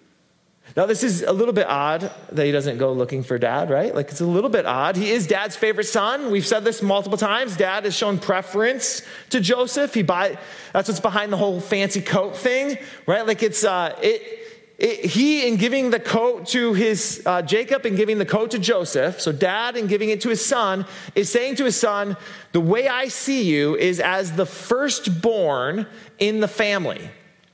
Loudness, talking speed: -21 LUFS, 205 wpm